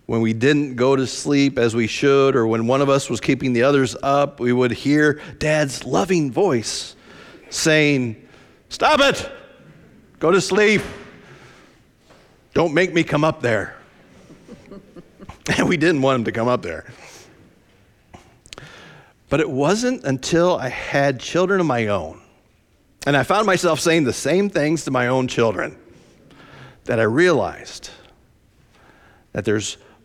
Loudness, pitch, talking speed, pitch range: -19 LUFS, 140 Hz, 145 wpm, 125-160 Hz